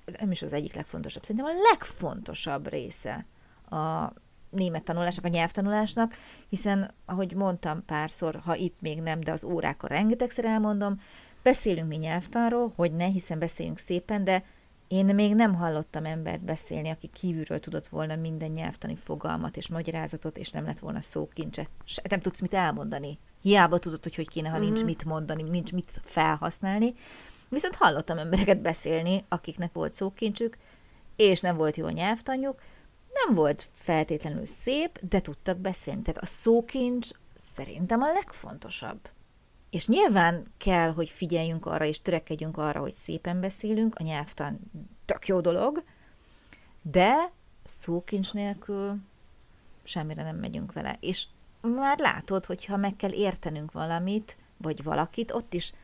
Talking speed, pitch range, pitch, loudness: 145 wpm, 165-210 Hz, 180 Hz, -29 LUFS